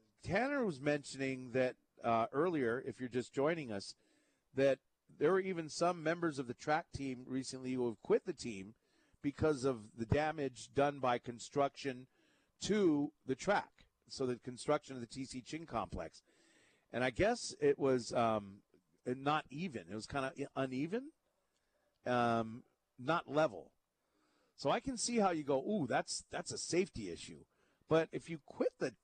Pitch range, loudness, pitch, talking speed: 125-155 Hz, -38 LUFS, 135 Hz, 165 wpm